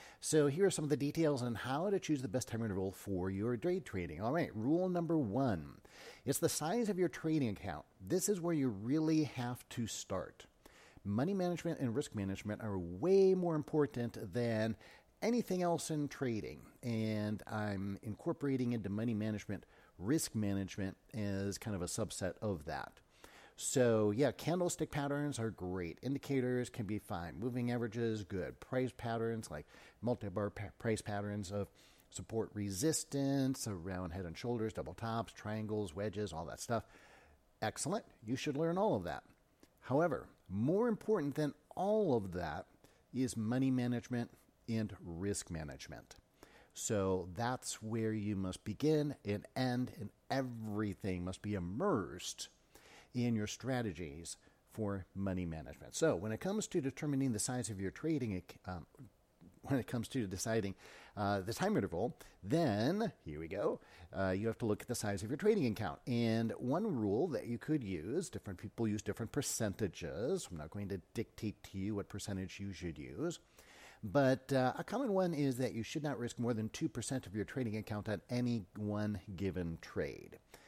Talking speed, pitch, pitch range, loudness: 170 wpm, 115 Hz, 100-135 Hz, -38 LUFS